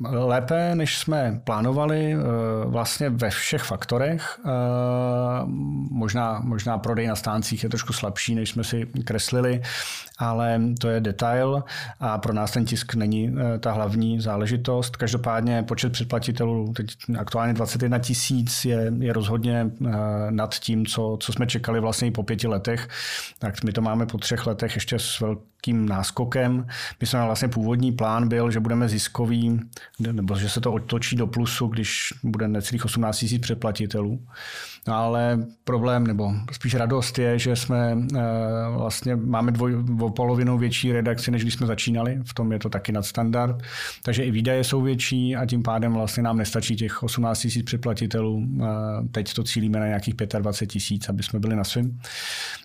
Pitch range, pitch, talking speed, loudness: 110-120 Hz, 115 Hz, 160 wpm, -24 LUFS